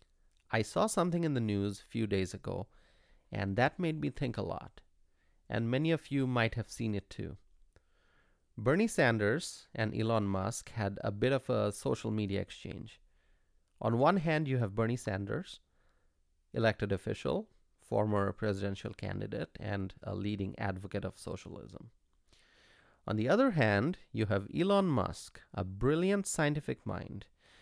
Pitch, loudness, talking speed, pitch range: 105 Hz, -34 LUFS, 150 wpm, 95-125 Hz